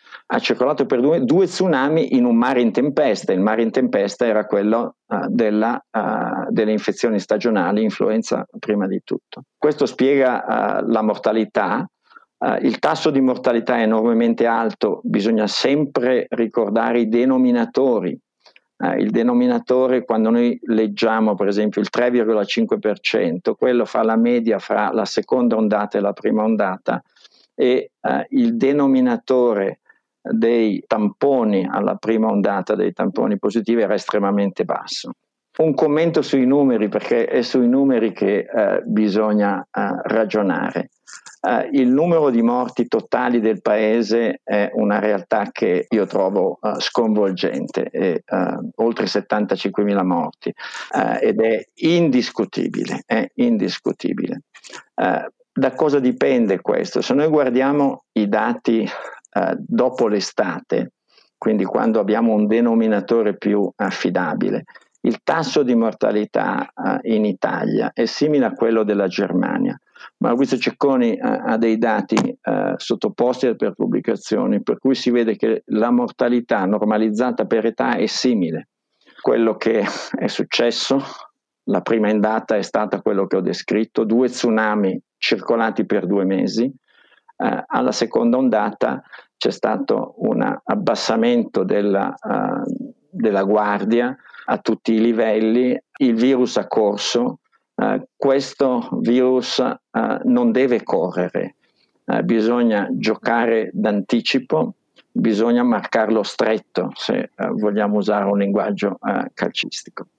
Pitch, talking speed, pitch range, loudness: 115 Hz, 125 wpm, 110-135 Hz, -19 LUFS